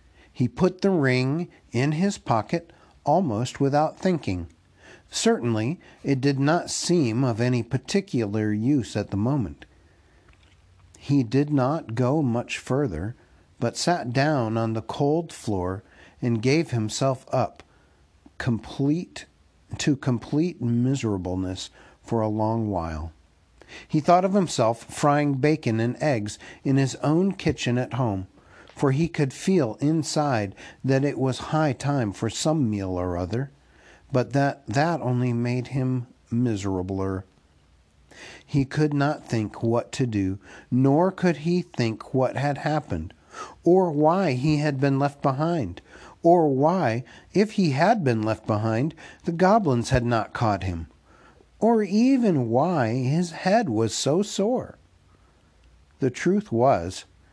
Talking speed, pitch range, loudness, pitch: 135 wpm, 105-155 Hz, -24 LUFS, 130 Hz